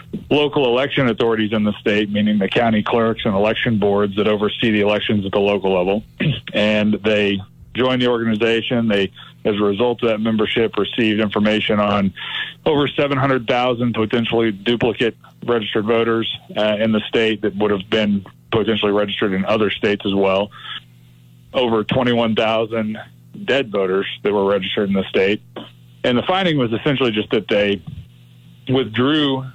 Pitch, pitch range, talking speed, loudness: 110 Hz, 100-115 Hz, 155 wpm, -18 LUFS